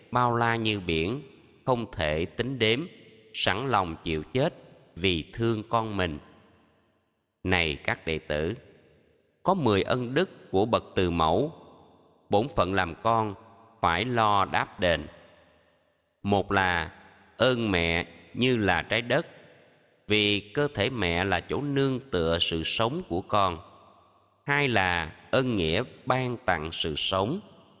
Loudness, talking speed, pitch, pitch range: -27 LUFS, 140 wpm, 100 Hz, 85-115 Hz